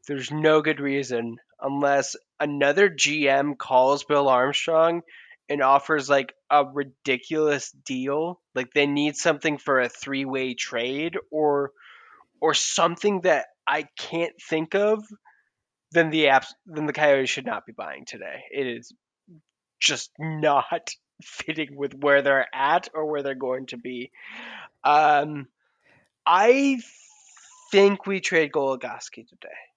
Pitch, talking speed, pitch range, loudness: 145 Hz, 130 wpm, 135-165 Hz, -23 LUFS